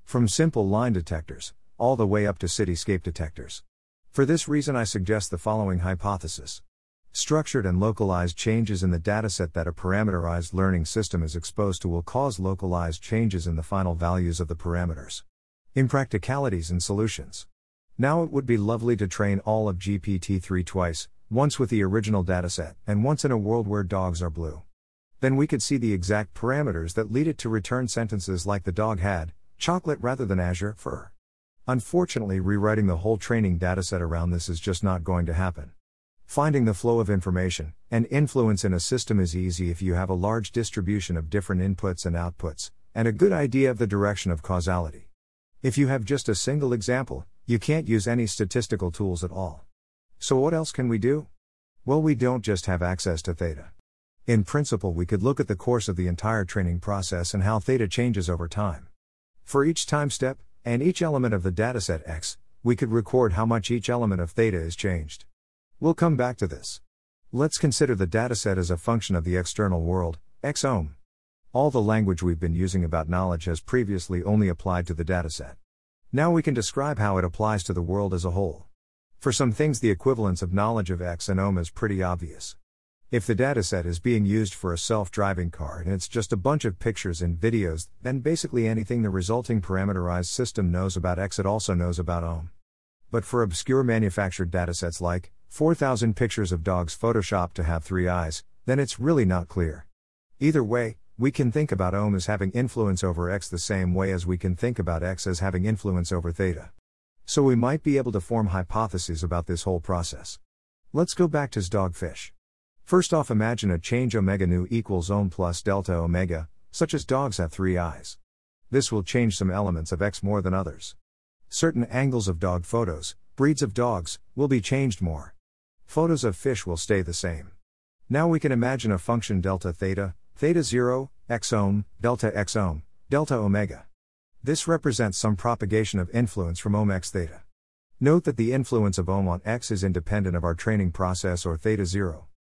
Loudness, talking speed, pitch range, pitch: -26 LUFS, 195 wpm, 90-115 Hz, 100 Hz